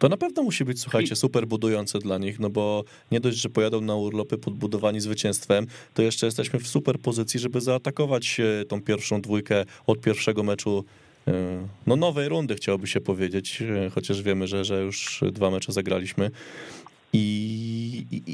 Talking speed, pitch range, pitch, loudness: 160 wpm, 100-120 Hz, 105 Hz, -26 LUFS